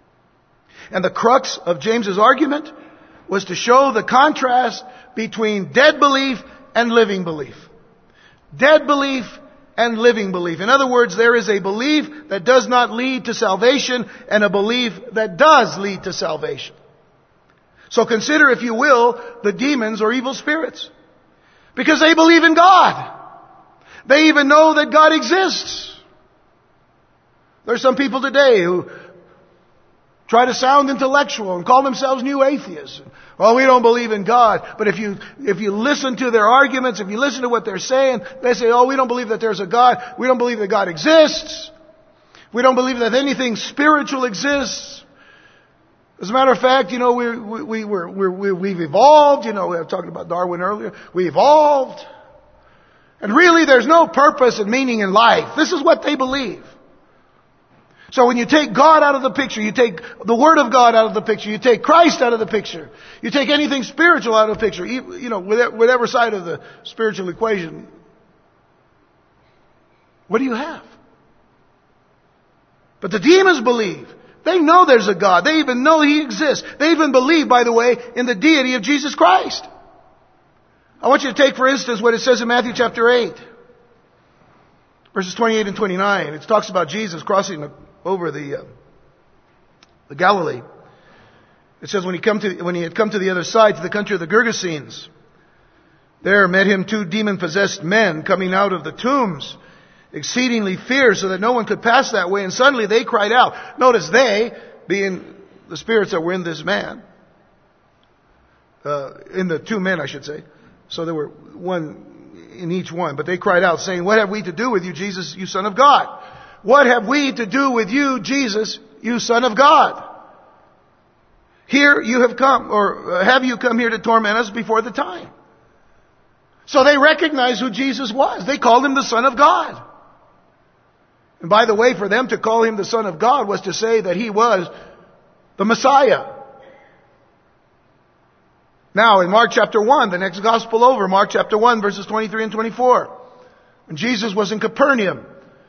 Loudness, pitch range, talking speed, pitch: -15 LUFS, 205-275 Hz, 180 wpm, 235 Hz